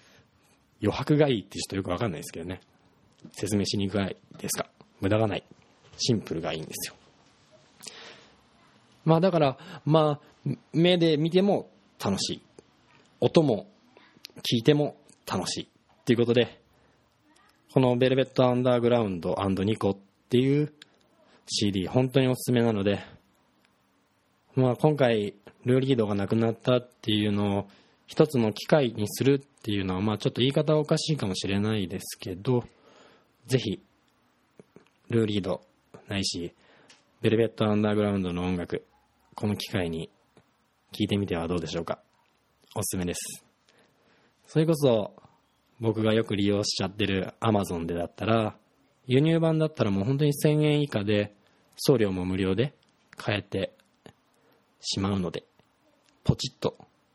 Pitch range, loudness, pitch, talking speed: 100-135 Hz, -27 LUFS, 110 Hz, 295 characters per minute